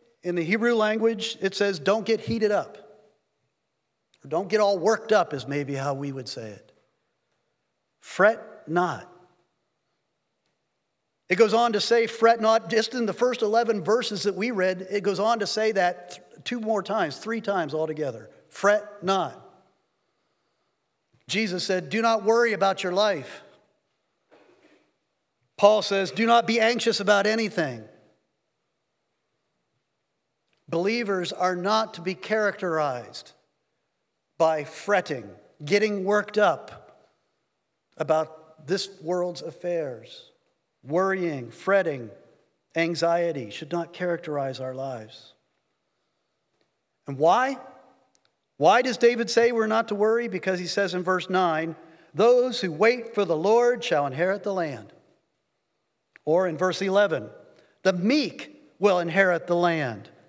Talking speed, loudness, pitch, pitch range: 130 wpm, -24 LUFS, 195 Hz, 170-225 Hz